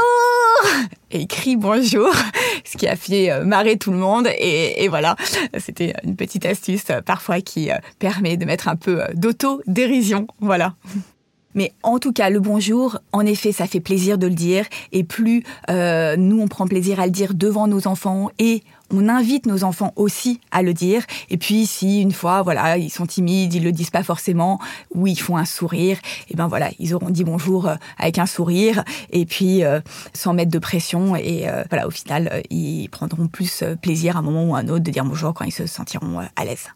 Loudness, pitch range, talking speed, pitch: -19 LUFS, 175-205 Hz, 205 wpm, 190 Hz